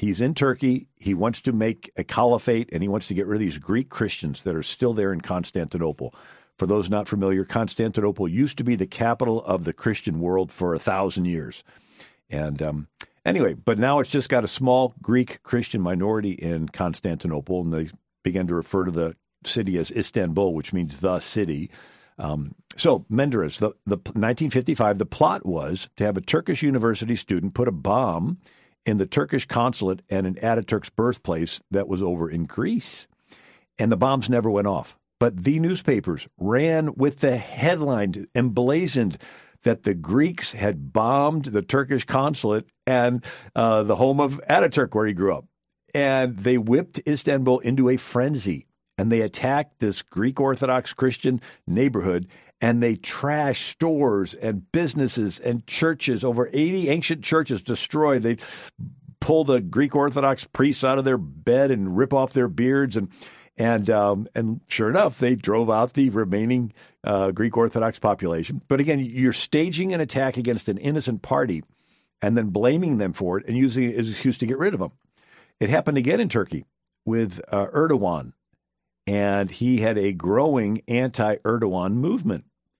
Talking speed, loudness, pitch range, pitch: 170 wpm, -23 LUFS, 100-135 Hz, 120 Hz